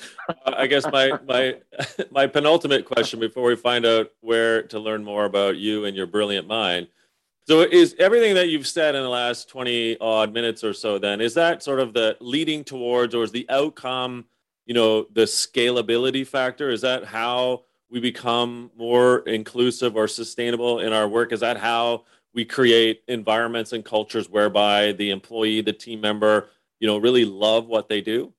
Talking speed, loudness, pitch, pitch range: 180 wpm, -21 LUFS, 115 Hz, 110-125 Hz